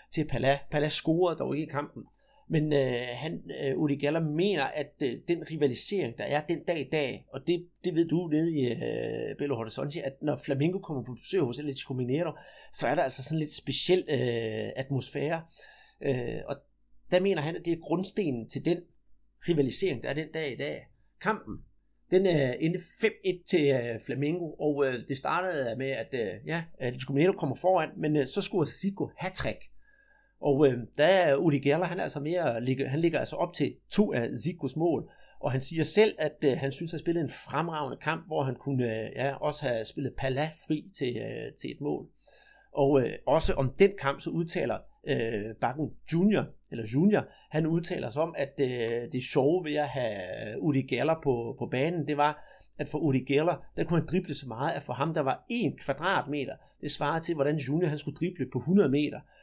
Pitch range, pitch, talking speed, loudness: 135-170 Hz, 150 Hz, 205 wpm, -30 LUFS